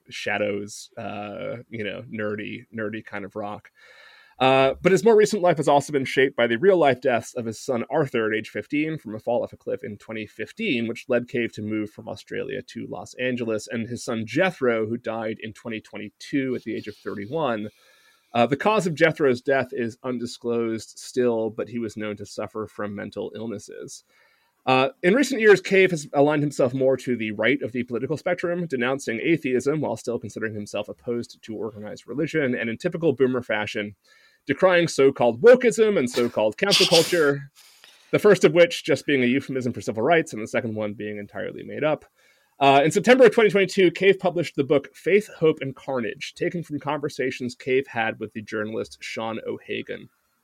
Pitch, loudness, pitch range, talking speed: 125 Hz, -23 LUFS, 110-155 Hz, 195 wpm